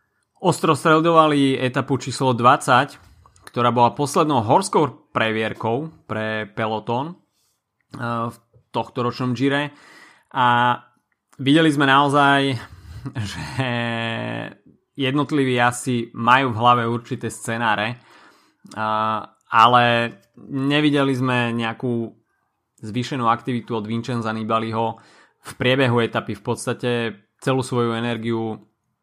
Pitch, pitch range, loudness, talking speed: 120 Hz, 115-135 Hz, -20 LUFS, 90 wpm